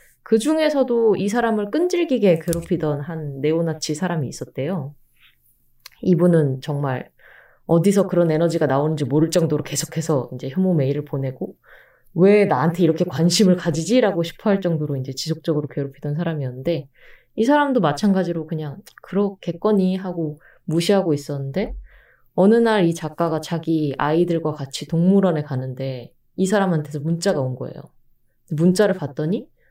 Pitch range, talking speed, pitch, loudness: 145-190 Hz, 345 characters per minute, 165 Hz, -20 LUFS